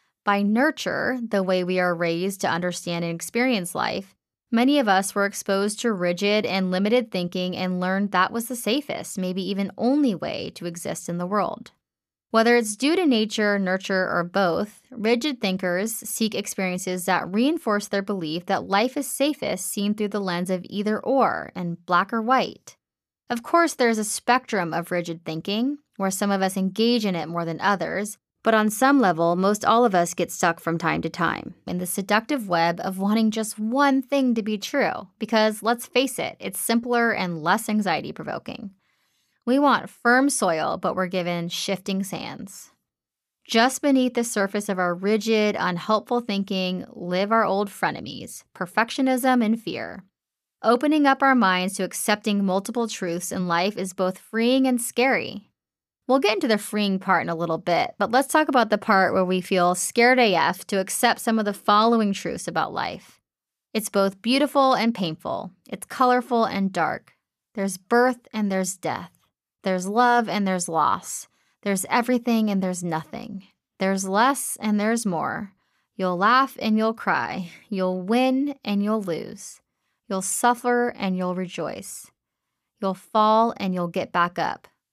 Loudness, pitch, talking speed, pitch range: -23 LUFS, 205 Hz, 170 wpm, 185-235 Hz